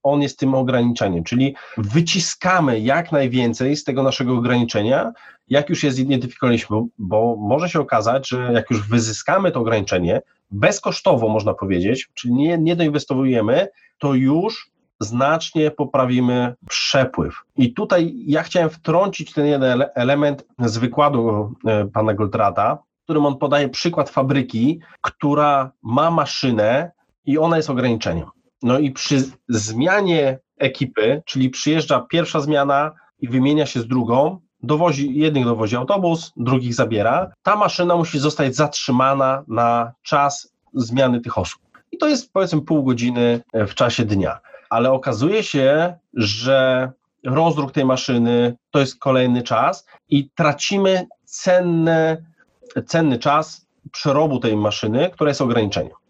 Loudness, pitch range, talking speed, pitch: -19 LUFS, 120-155 Hz, 135 wpm, 135 Hz